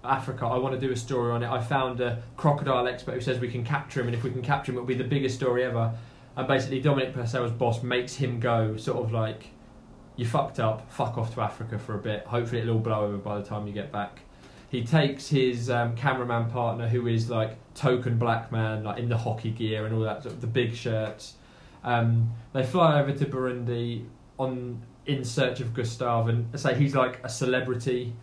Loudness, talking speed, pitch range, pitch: -28 LUFS, 225 wpm, 115-130 Hz, 125 Hz